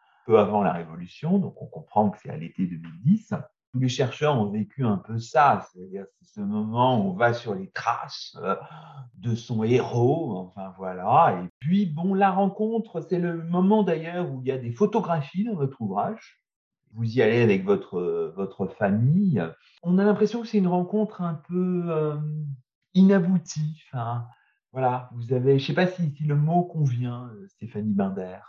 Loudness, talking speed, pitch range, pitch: -25 LUFS, 185 wpm, 115-180 Hz, 145 Hz